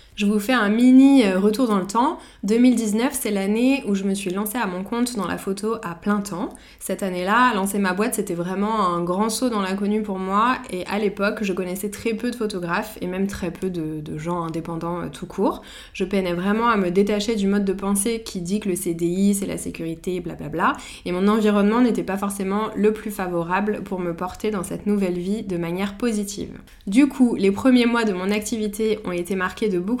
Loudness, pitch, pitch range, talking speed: -22 LUFS, 205 Hz, 185-220 Hz, 225 wpm